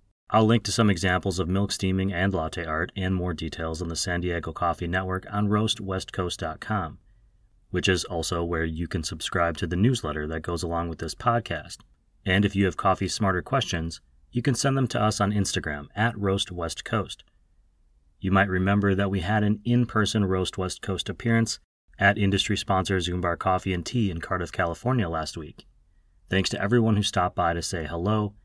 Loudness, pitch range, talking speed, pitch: -26 LUFS, 85-105 Hz, 185 wpm, 95 Hz